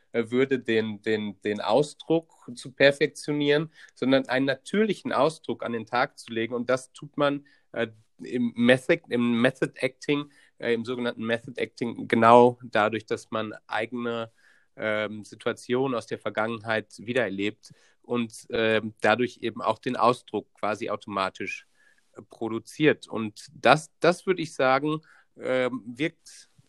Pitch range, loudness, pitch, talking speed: 110-135 Hz, -26 LUFS, 120 Hz, 135 wpm